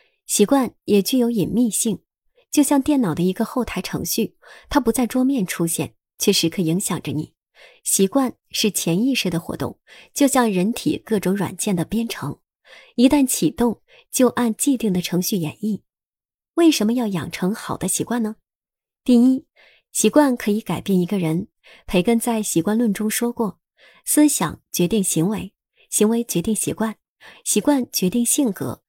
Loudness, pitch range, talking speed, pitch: -20 LUFS, 185-245 Hz, 240 characters per minute, 215 Hz